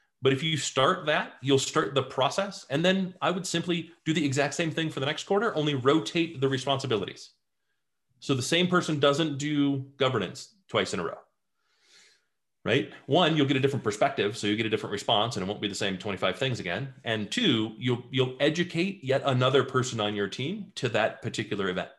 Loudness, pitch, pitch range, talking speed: -27 LUFS, 140 Hz, 130-160 Hz, 205 wpm